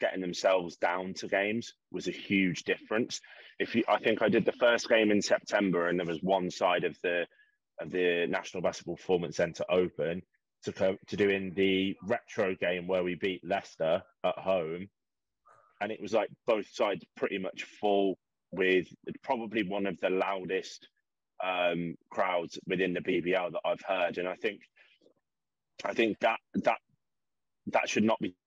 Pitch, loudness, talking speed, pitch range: 95 Hz, -31 LUFS, 170 wpm, 90-100 Hz